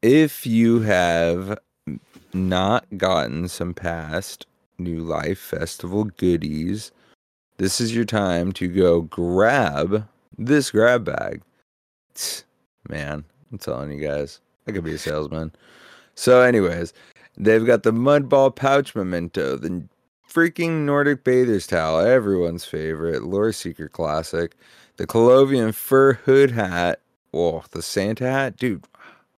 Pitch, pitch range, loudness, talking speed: 95 Hz, 85-125 Hz, -21 LUFS, 120 wpm